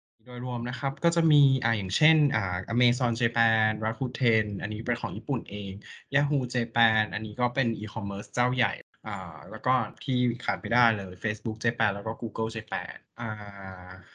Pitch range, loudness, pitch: 110-125 Hz, -27 LUFS, 115 Hz